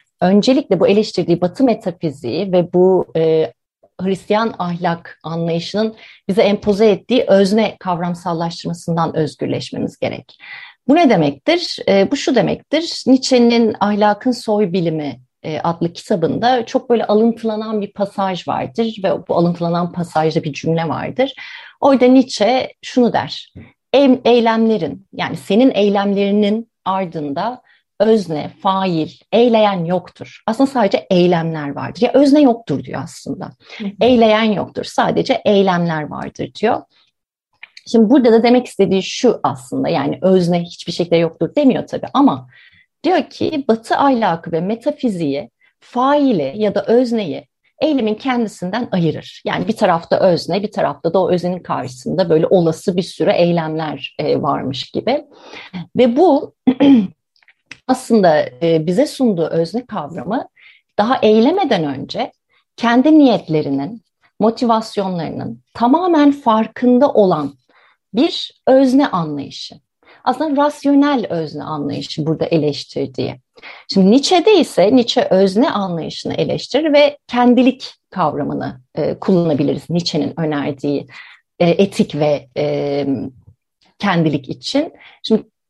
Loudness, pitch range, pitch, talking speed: -16 LUFS, 170-245 Hz, 200 Hz, 115 wpm